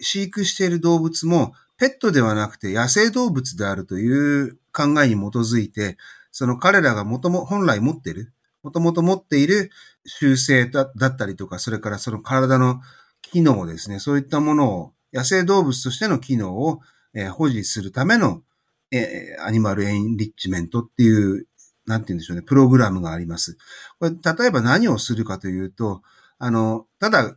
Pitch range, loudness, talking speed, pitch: 105-160 Hz, -20 LUFS, 345 characters per minute, 130 Hz